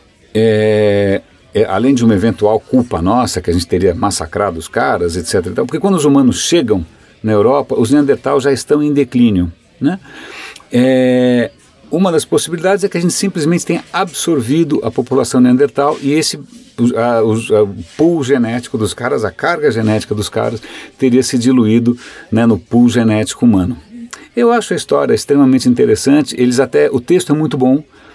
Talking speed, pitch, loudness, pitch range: 175 wpm, 125 Hz, -13 LUFS, 110-150 Hz